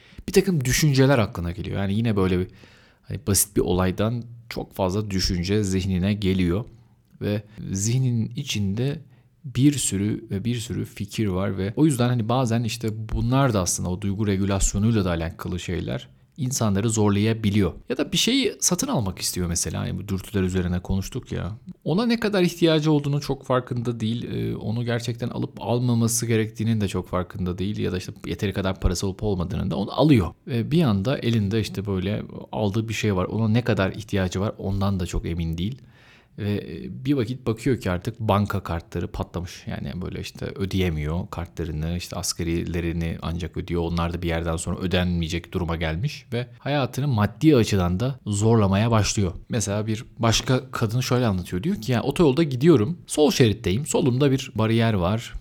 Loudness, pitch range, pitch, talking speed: -24 LUFS, 95-120 Hz, 105 Hz, 170 wpm